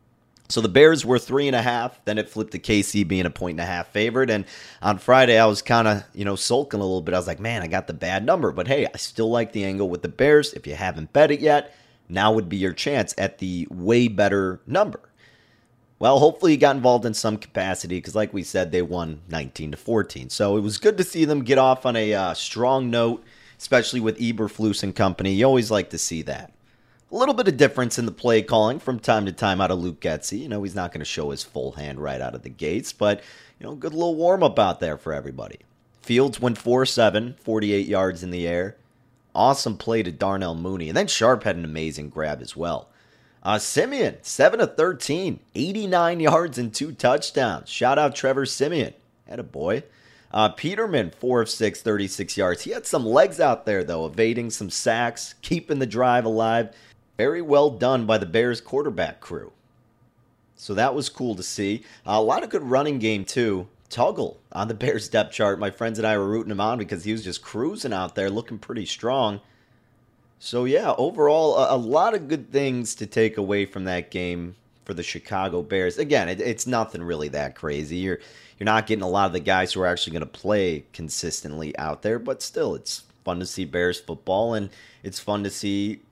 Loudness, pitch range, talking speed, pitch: -23 LUFS, 95-120 Hz, 215 wpm, 110 Hz